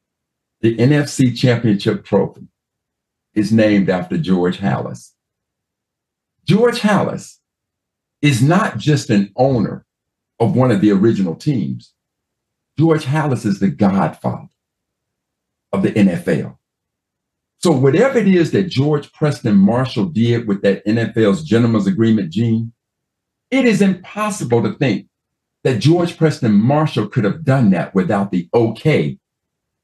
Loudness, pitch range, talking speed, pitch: -16 LUFS, 105-155 Hz, 125 wpm, 120 Hz